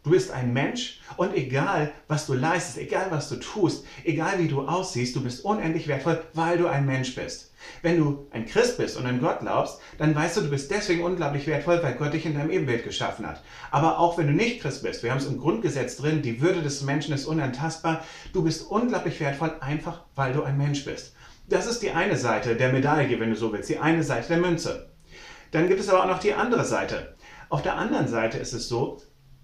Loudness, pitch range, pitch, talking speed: -26 LUFS, 140-170 Hz, 155 Hz, 230 wpm